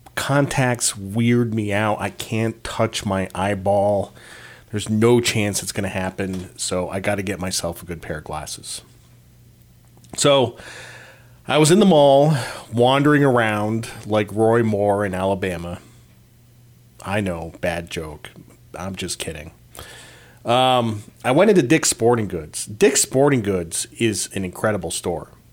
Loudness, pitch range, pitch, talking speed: -20 LUFS, 95-120 Hz, 105 Hz, 145 wpm